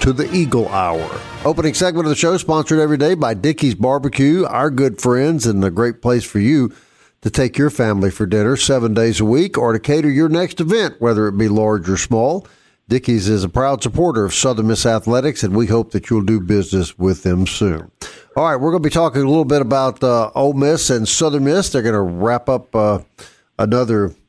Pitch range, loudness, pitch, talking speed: 110-145 Hz, -16 LUFS, 120 Hz, 220 wpm